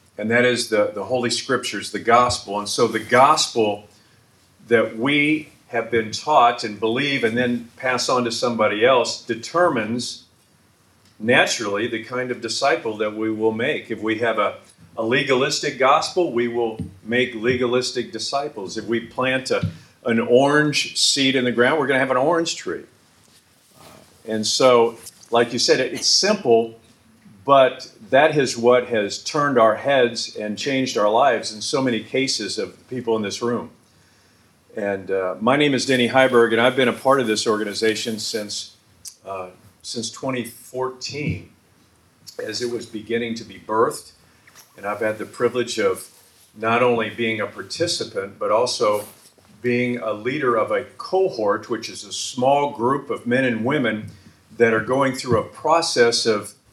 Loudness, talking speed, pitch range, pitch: -20 LUFS, 165 wpm, 110-130 Hz, 115 Hz